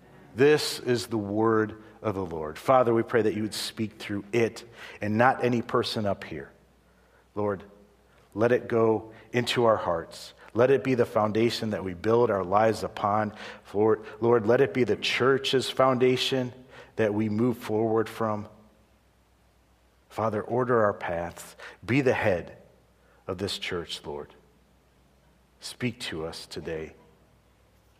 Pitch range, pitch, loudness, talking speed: 105-120 Hz, 110 Hz, -26 LUFS, 145 wpm